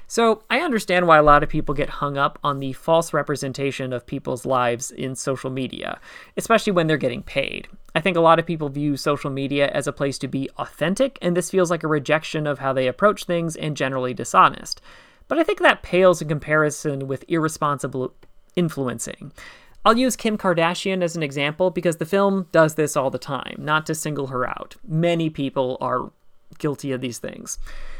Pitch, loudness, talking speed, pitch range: 155 Hz, -21 LUFS, 195 wpm, 140-175 Hz